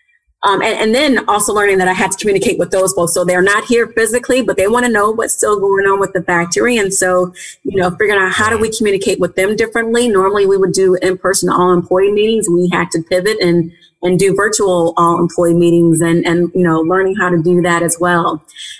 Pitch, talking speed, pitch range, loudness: 190 Hz, 230 wpm, 175-210 Hz, -12 LUFS